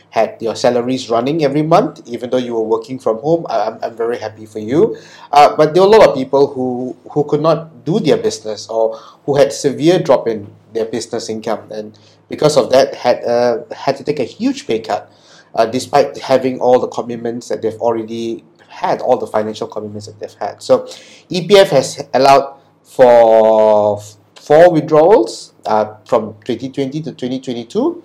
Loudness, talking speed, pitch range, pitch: -14 LUFS, 180 wpm, 110-145 Hz, 125 Hz